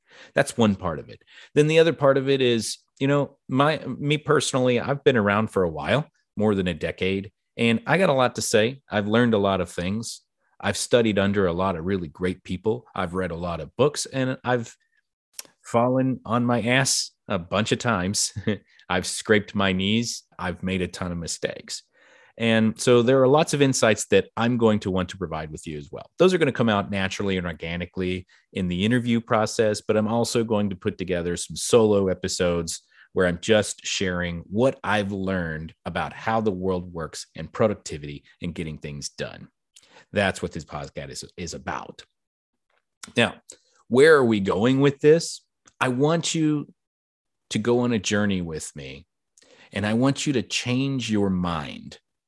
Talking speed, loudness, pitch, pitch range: 190 wpm, -23 LUFS, 105 Hz, 90-125 Hz